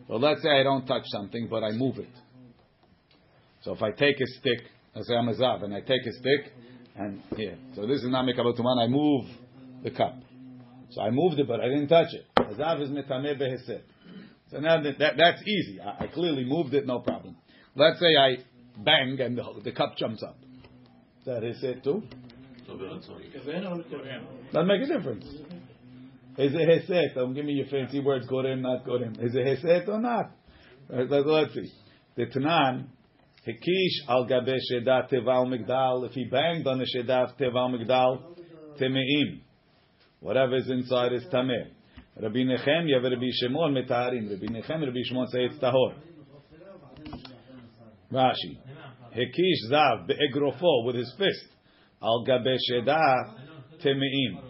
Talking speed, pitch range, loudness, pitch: 160 wpm, 125-145 Hz, -26 LUFS, 130 Hz